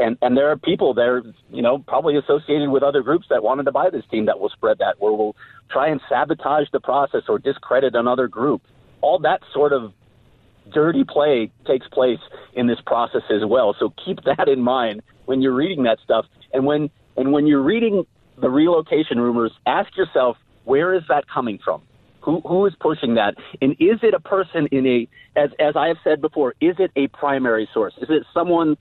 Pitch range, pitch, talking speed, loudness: 120-155 Hz, 140 Hz, 205 wpm, -19 LUFS